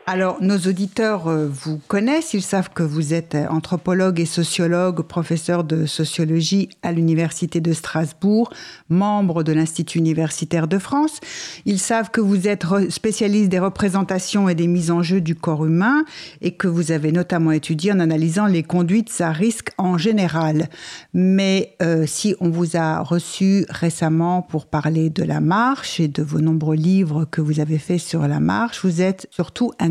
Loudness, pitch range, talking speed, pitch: -19 LUFS, 160-195 Hz, 170 wpm, 175 Hz